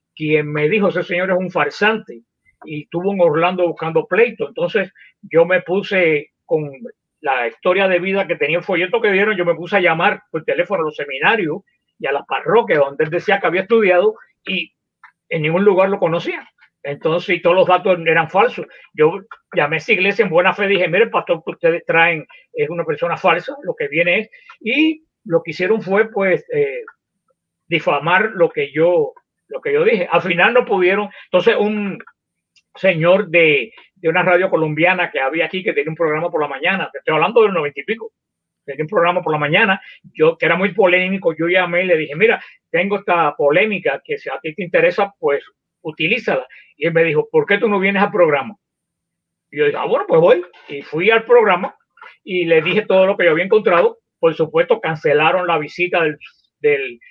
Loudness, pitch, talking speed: -16 LUFS, 200 Hz, 205 wpm